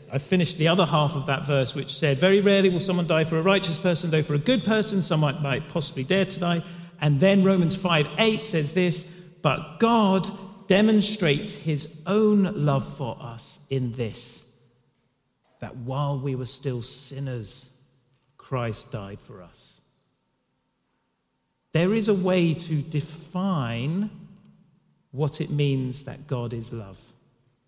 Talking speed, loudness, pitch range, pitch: 150 wpm, -24 LUFS, 130-185 Hz, 155 Hz